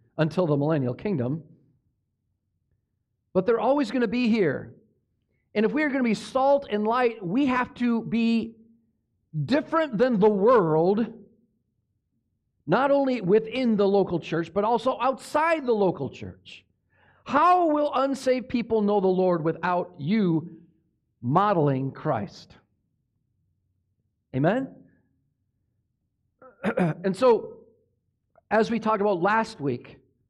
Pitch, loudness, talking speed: 195 Hz, -24 LUFS, 120 wpm